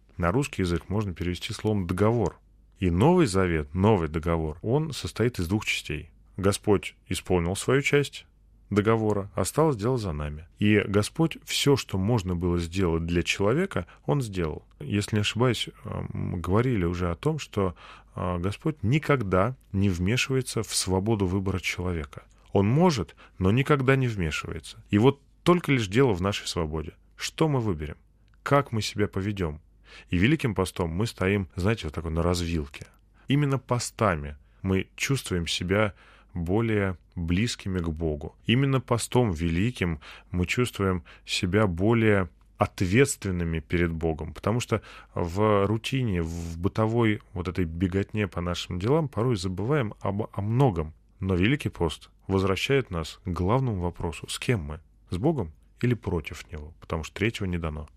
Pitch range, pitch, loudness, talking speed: 85-115 Hz, 100 Hz, -27 LUFS, 145 wpm